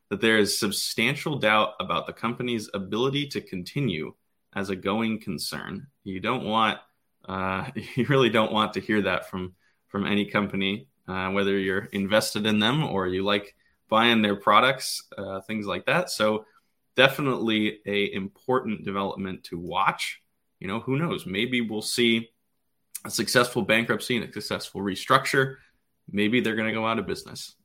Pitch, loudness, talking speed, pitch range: 105 Hz, -25 LUFS, 165 wpm, 100-115 Hz